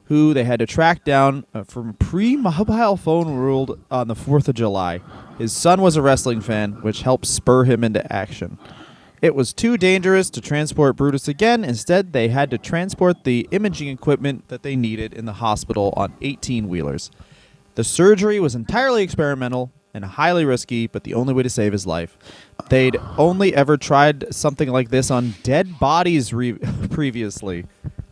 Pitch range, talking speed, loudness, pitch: 115-155 Hz, 170 wpm, -19 LUFS, 130 Hz